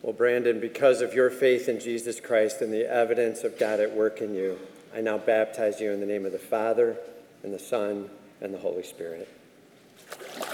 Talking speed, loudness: 200 wpm, -26 LUFS